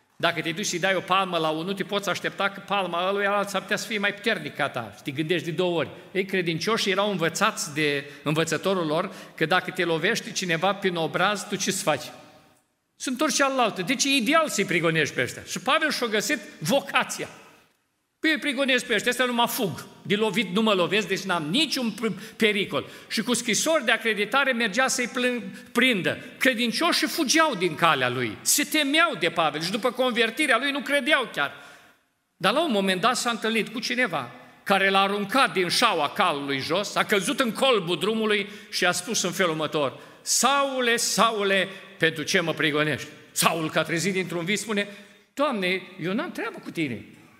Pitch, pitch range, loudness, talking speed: 200 Hz, 175-240 Hz, -24 LUFS, 190 wpm